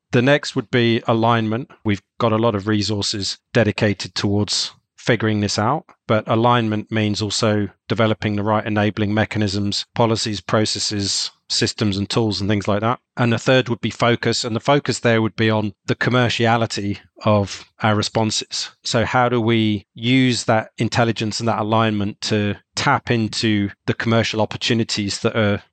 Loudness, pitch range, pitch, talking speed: -19 LUFS, 105-115 Hz, 110 Hz, 165 wpm